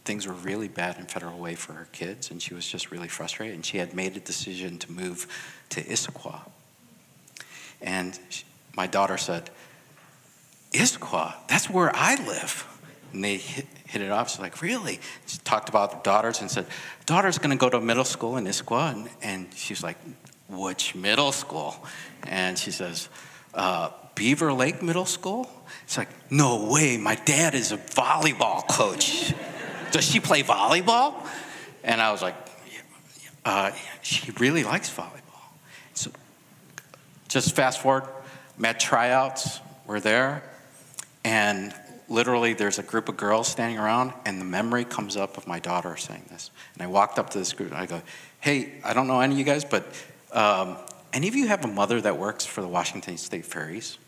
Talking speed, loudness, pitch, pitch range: 180 wpm, -26 LUFS, 115 Hz, 95-135 Hz